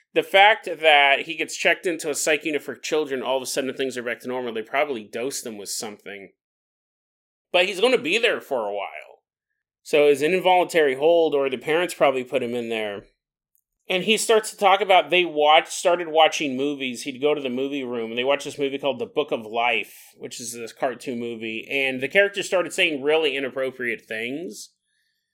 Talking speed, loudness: 210 wpm, -22 LUFS